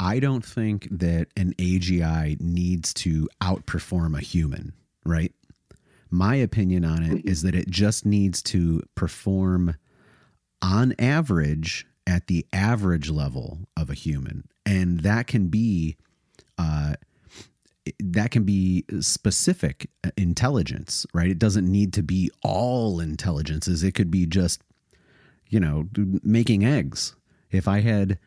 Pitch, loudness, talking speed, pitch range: 95 Hz, -24 LUFS, 130 wpm, 85-105 Hz